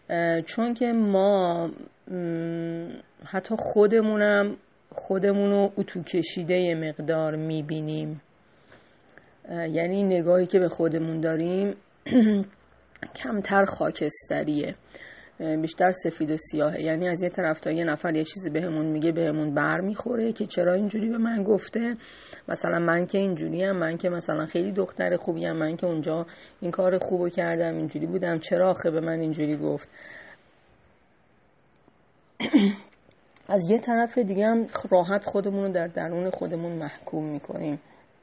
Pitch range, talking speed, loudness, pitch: 160-200 Hz, 130 wpm, -26 LUFS, 175 Hz